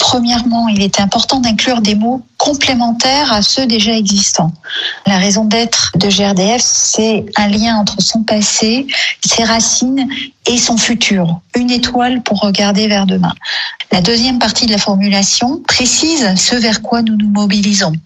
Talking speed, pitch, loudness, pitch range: 155 wpm, 225 Hz, -11 LUFS, 205-245 Hz